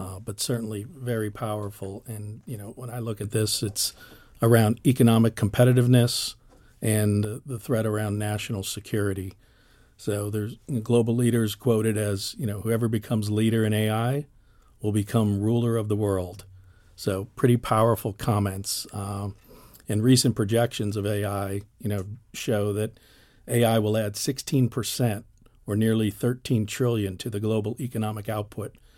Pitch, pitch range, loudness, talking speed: 110 Hz, 105-120 Hz, -25 LUFS, 150 wpm